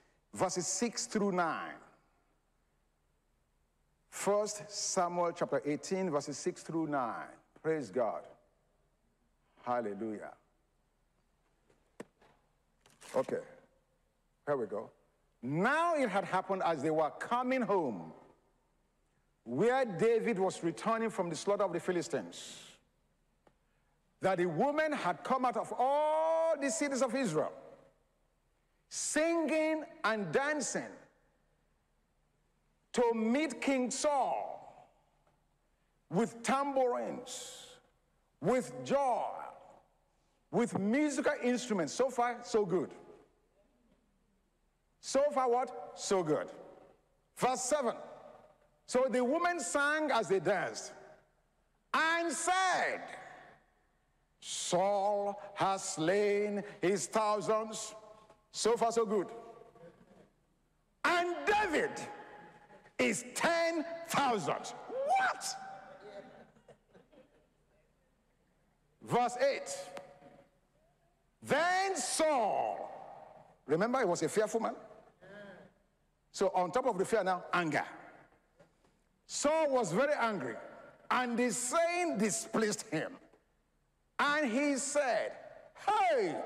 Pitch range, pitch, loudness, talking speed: 190-275 Hz, 225 Hz, -33 LUFS, 90 wpm